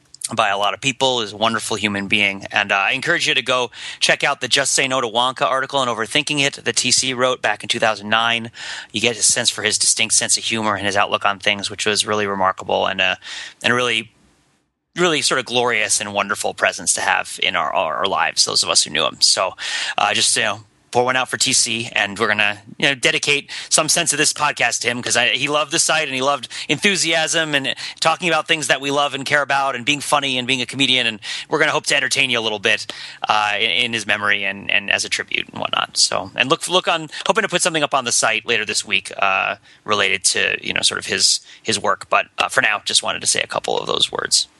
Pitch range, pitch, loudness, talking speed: 110-150 Hz, 125 Hz, -17 LUFS, 255 wpm